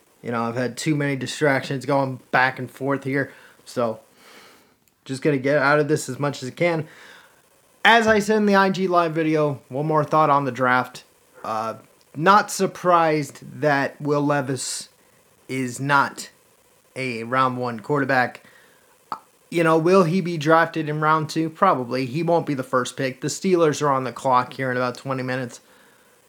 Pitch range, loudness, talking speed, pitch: 130-170 Hz, -21 LUFS, 180 wpm, 145 Hz